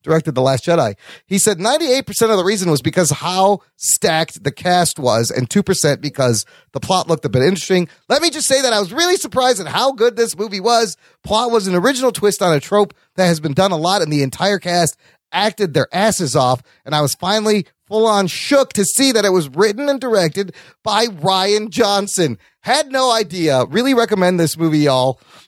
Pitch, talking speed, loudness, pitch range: 190 Hz, 210 wpm, -16 LUFS, 160-220 Hz